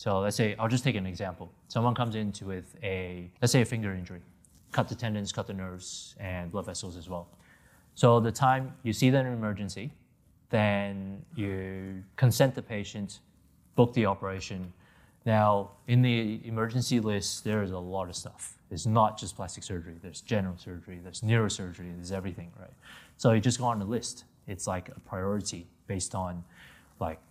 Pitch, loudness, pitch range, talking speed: 100 Hz, -30 LUFS, 90-115 Hz, 185 wpm